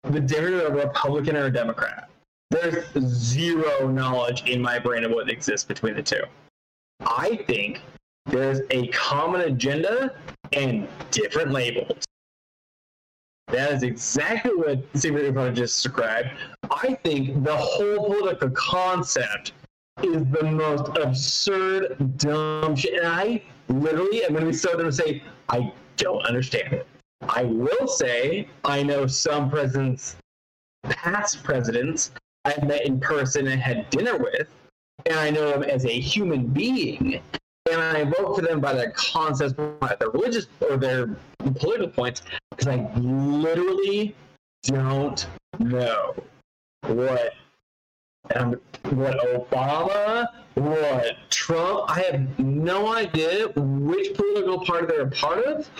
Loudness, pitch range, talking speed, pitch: -24 LUFS, 130-170 Hz, 130 wpm, 145 Hz